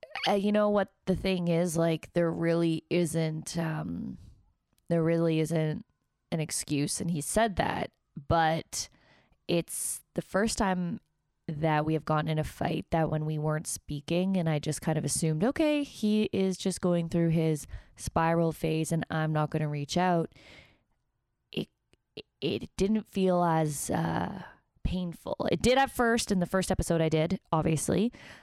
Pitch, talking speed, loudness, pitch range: 165 Hz, 165 wpm, -29 LUFS, 155-190 Hz